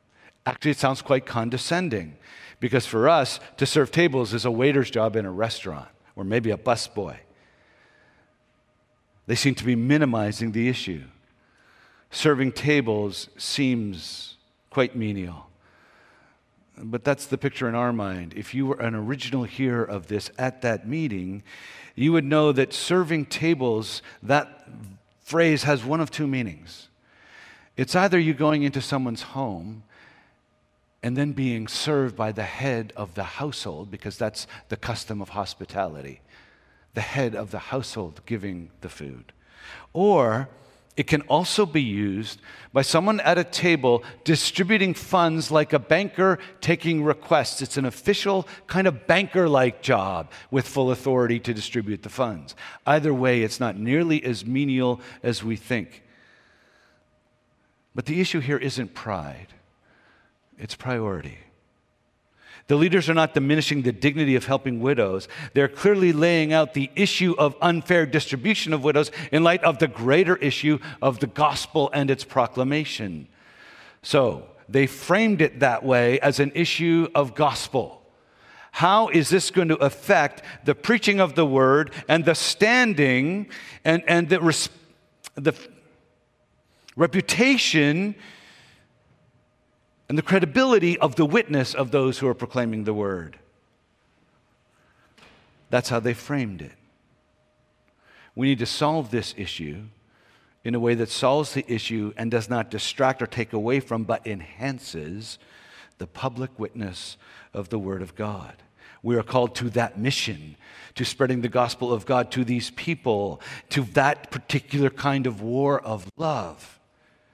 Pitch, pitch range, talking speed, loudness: 130 Hz, 115-150 Hz, 145 wpm, -23 LUFS